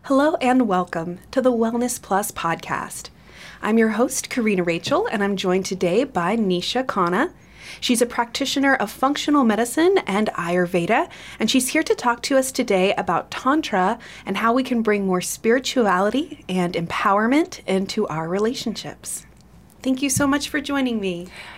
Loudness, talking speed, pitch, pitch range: -21 LUFS, 160 wpm, 225 Hz, 190-260 Hz